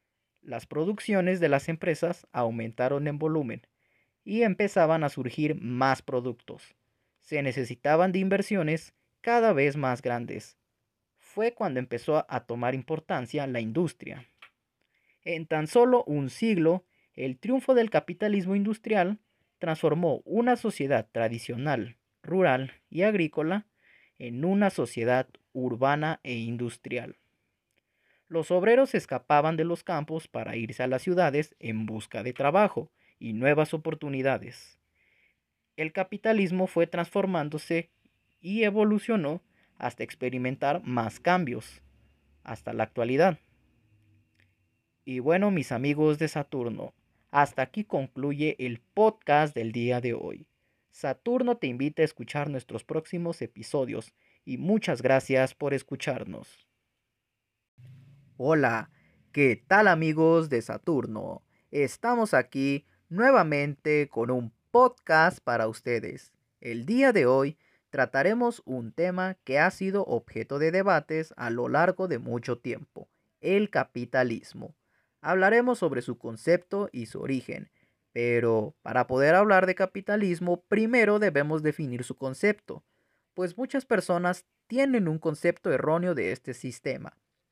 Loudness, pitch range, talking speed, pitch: -27 LUFS, 120-180 Hz, 120 wpm, 145 Hz